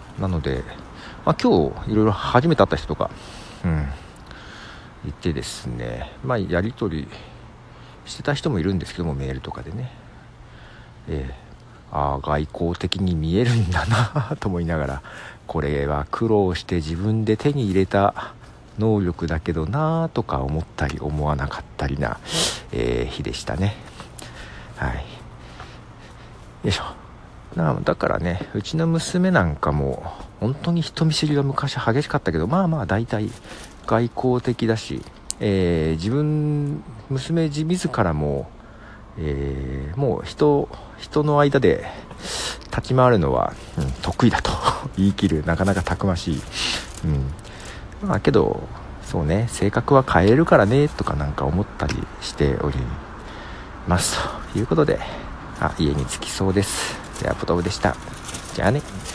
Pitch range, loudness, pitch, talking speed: 75-120 Hz, -22 LUFS, 100 Hz, 265 characters per minute